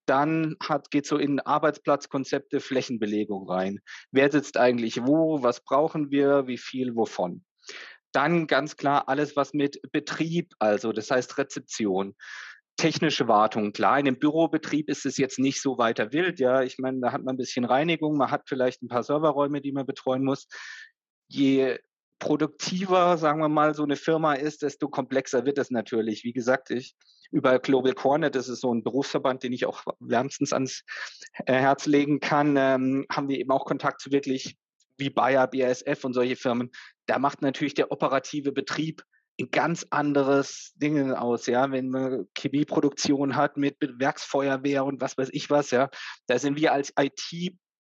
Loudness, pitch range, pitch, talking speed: -26 LUFS, 130-150 Hz, 140 Hz, 175 wpm